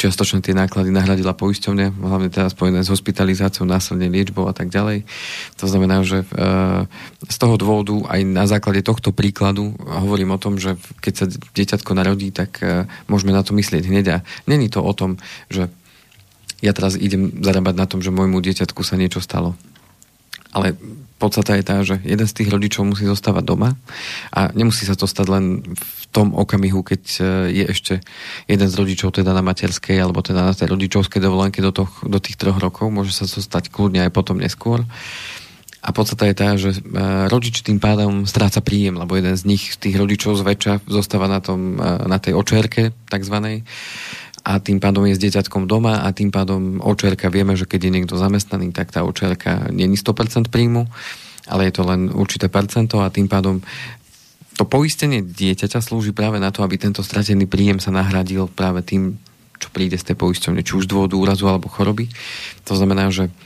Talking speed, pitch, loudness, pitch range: 185 wpm, 95 Hz, -18 LUFS, 95-105 Hz